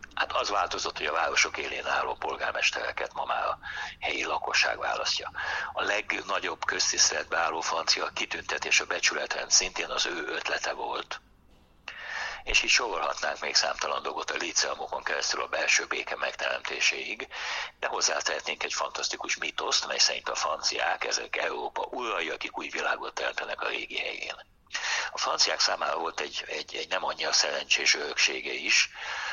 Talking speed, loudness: 150 wpm, -27 LUFS